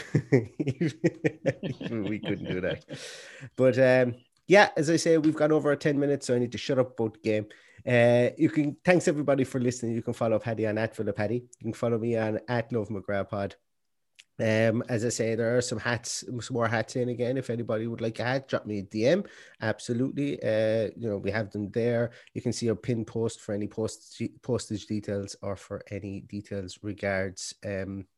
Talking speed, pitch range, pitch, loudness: 205 wpm, 105-130 Hz, 115 Hz, -28 LUFS